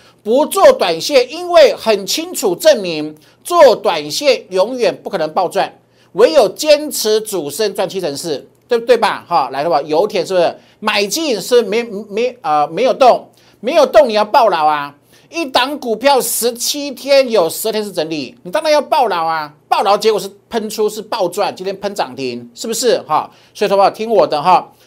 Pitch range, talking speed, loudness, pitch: 195-295 Hz, 270 characters per minute, -14 LUFS, 220 Hz